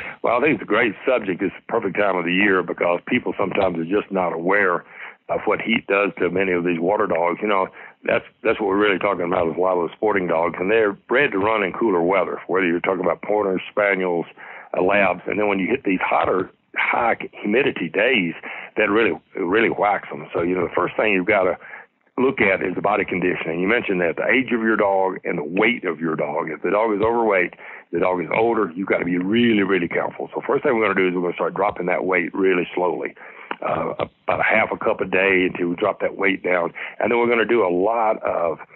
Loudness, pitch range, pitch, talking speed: -20 LUFS, 90-100 Hz, 95 Hz, 250 wpm